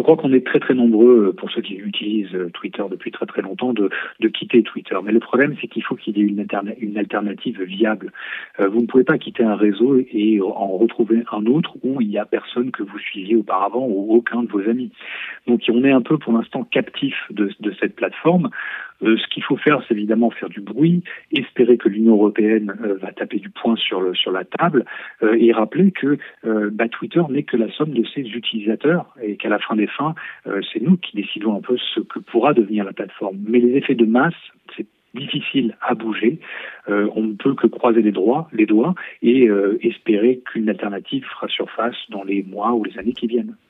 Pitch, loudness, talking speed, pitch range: 115 Hz, -19 LUFS, 225 wpm, 105-125 Hz